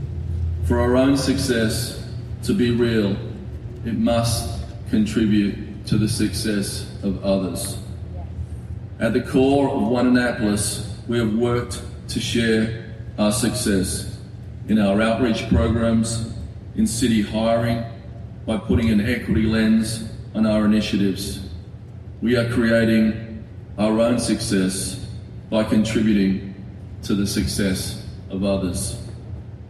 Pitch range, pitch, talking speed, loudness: 100-115 Hz, 110 Hz, 115 wpm, -21 LUFS